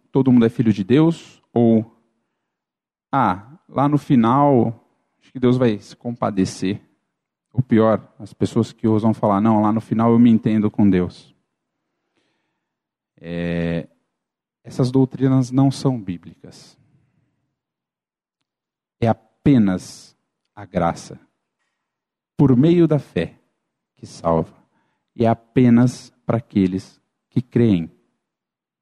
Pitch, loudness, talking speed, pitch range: 115 Hz, -18 LUFS, 115 wpm, 100-130 Hz